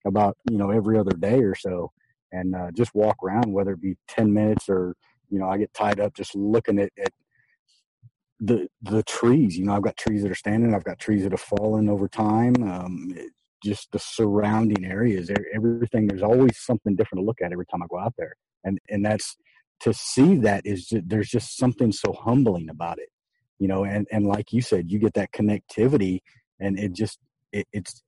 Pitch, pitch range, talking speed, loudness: 105 Hz, 100-110 Hz, 210 wpm, -24 LUFS